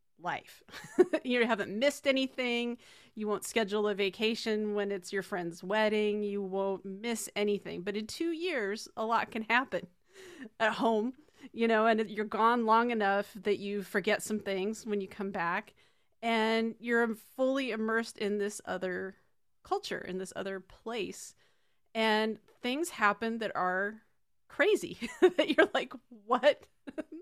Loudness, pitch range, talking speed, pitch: -32 LUFS, 205-240 Hz, 150 wpm, 220 Hz